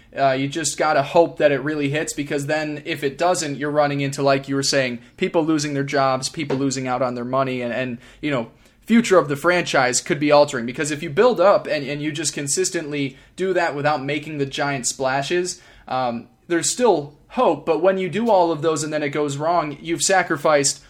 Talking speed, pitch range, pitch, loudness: 225 wpm, 140-165 Hz, 150 Hz, -20 LUFS